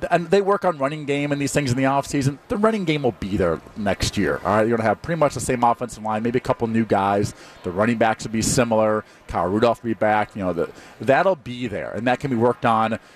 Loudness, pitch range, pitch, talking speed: -21 LUFS, 110-140 Hz, 120 Hz, 275 wpm